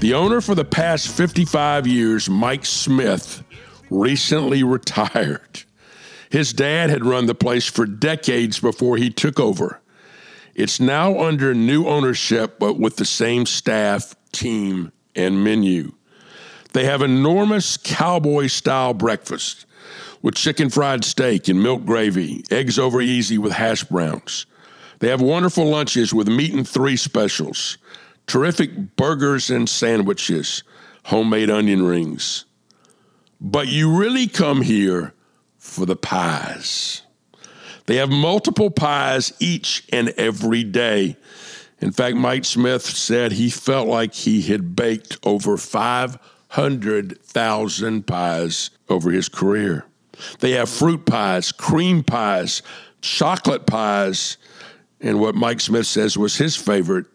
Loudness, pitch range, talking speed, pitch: -19 LUFS, 110-155 Hz, 125 wpm, 125 Hz